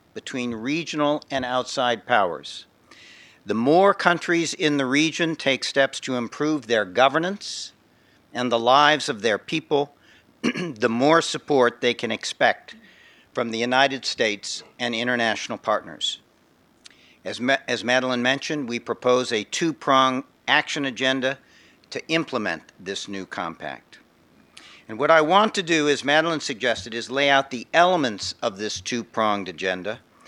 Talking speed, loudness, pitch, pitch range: 145 wpm, -22 LUFS, 130 Hz, 120-150 Hz